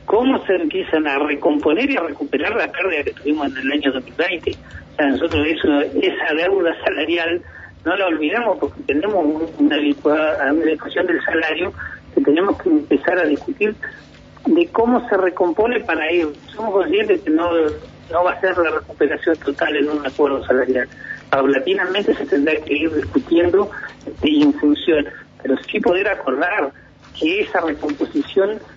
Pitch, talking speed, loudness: 175 Hz, 160 wpm, -18 LUFS